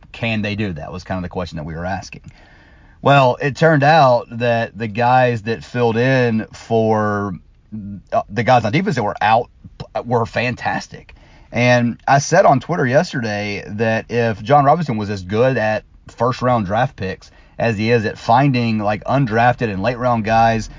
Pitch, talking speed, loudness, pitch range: 115 Hz, 180 wpm, -17 LUFS, 105-125 Hz